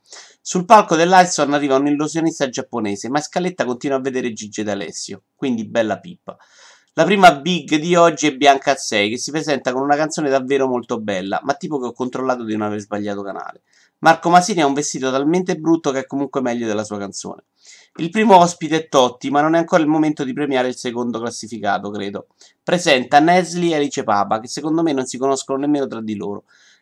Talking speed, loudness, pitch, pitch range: 200 wpm, -18 LUFS, 140 Hz, 120-160 Hz